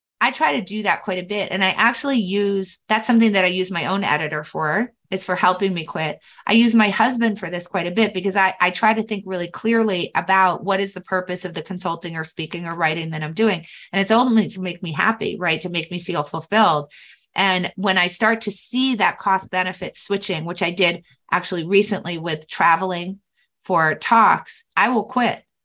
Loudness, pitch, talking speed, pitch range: -20 LUFS, 190 Hz, 220 wpm, 175-215 Hz